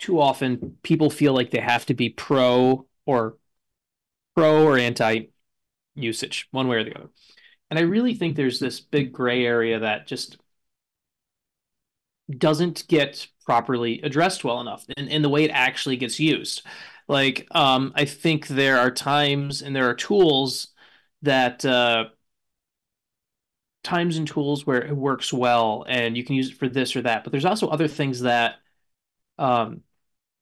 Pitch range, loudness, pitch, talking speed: 120-145 Hz, -22 LUFS, 130 Hz, 160 wpm